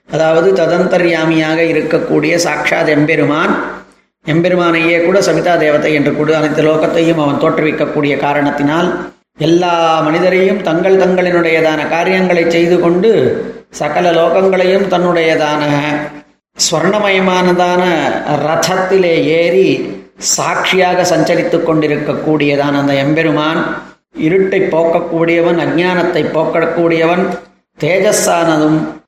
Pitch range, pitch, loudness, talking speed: 155-175 Hz, 165 Hz, -11 LUFS, 75 wpm